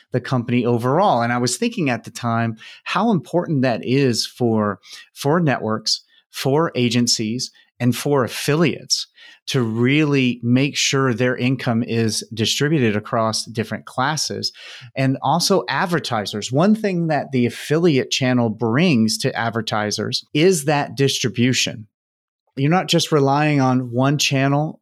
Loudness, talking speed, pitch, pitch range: -19 LUFS, 135 wpm, 130 Hz, 115-145 Hz